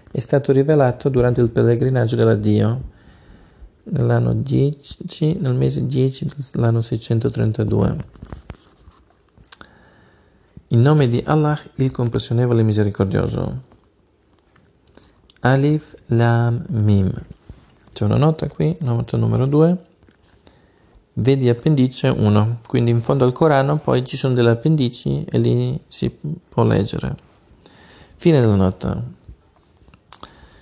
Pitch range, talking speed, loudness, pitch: 105-140 Hz, 100 wpm, -18 LUFS, 120 Hz